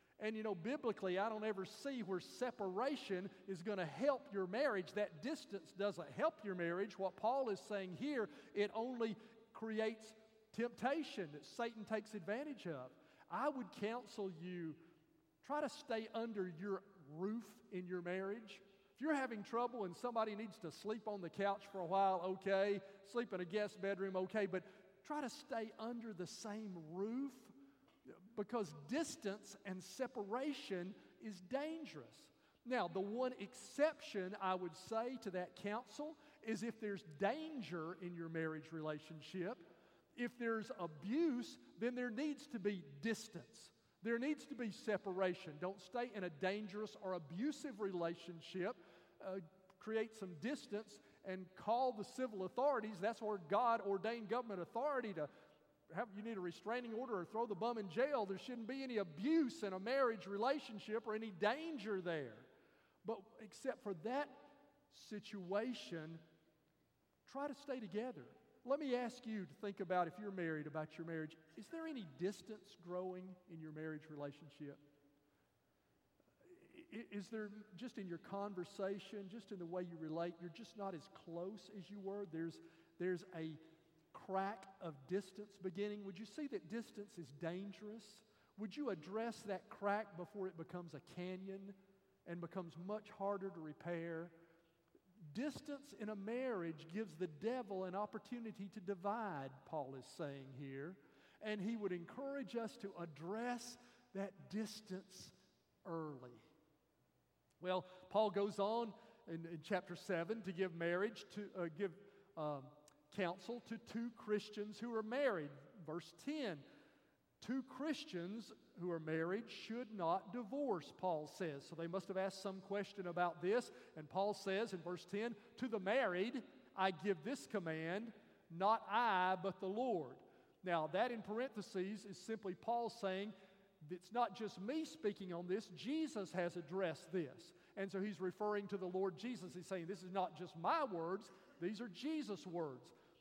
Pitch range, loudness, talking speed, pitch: 180-225 Hz, -45 LUFS, 155 wpm, 200 Hz